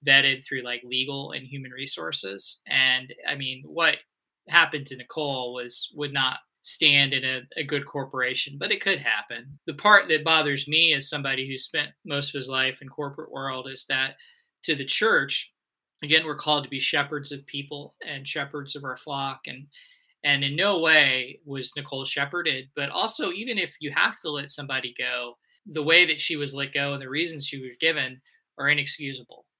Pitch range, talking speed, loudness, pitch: 130-150 Hz, 190 wpm, -24 LUFS, 140 Hz